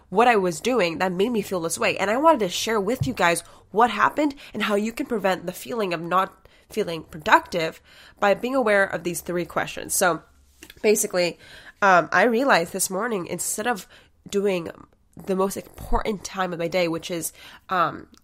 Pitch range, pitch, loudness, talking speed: 175-220 Hz, 190 Hz, -23 LUFS, 190 wpm